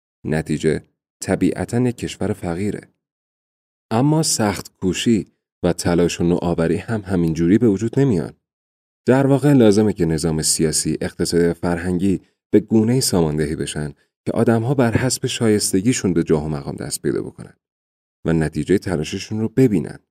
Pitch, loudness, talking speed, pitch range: 90 Hz, -19 LUFS, 145 wpm, 80-110 Hz